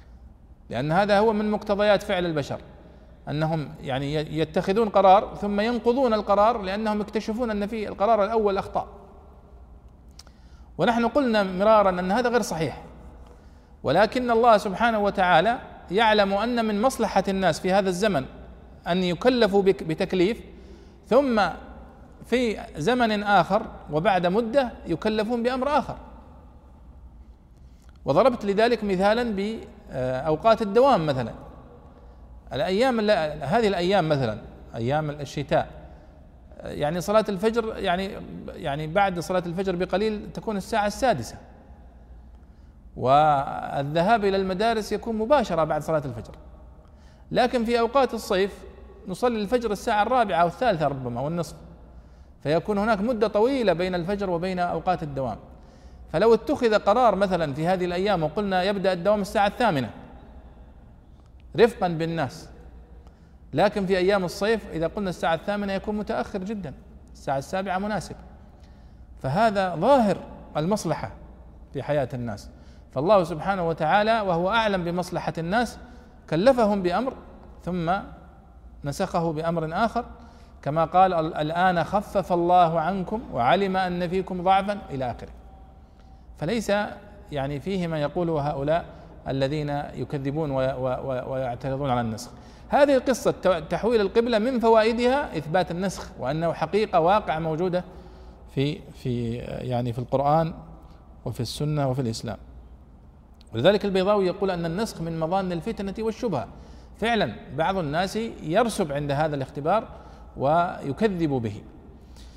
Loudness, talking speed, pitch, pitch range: -24 LUFS, 115 wpm, 175 Hz, 125-210 Hz